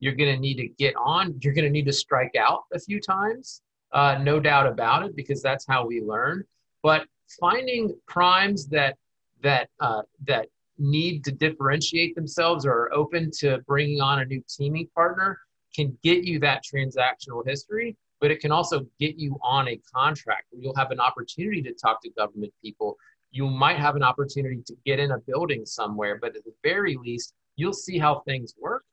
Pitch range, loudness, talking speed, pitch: 135-170 Hz, -24 LUFS, 195 wpm, 145 Hz